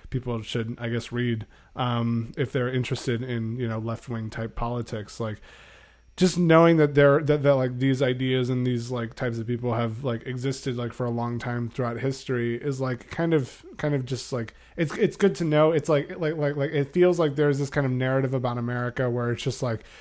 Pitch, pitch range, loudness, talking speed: 125 Hz, 120-140 Hz, -25 LUFS, 220 wpm